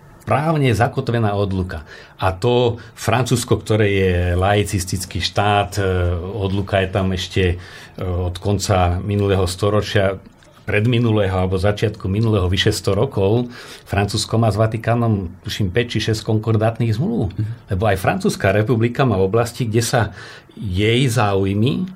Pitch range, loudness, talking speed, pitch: 95-115 Hz, -19 LUFS, 130 wpm, 105 Hz